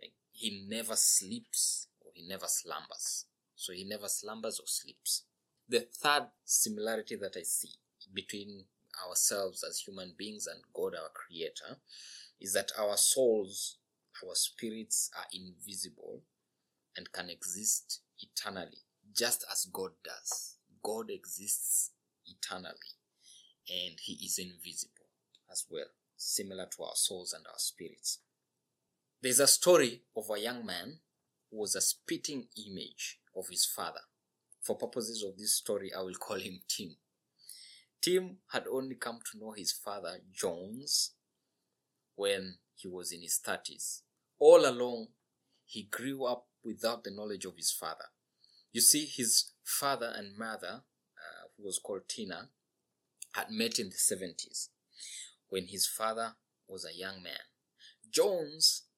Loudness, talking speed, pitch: -33 LUFS, 135 wpm, 115 Hz